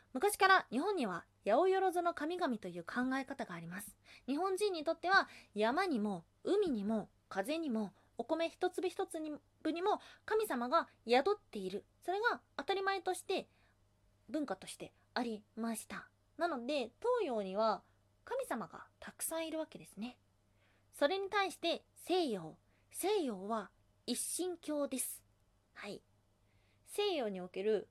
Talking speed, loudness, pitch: 265 characters per minute, -37 LUFS, 280 Hz